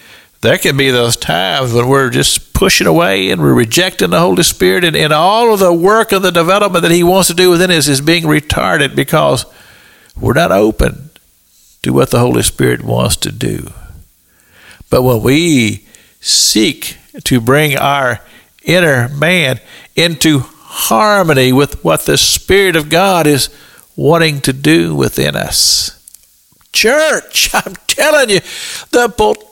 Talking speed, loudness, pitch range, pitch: 155 wpm, -10 LUFS, 125-180 Hz, 155 Hz